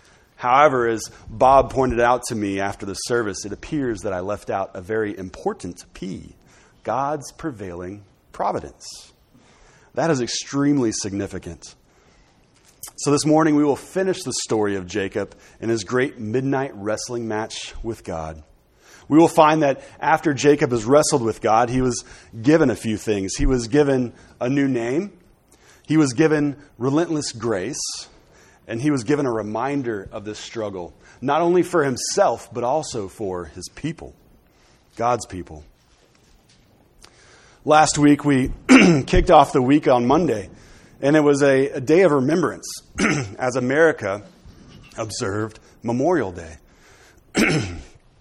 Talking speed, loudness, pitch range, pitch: 140 wpm, -20 LUFS, 105-145 Hz, 125 Hz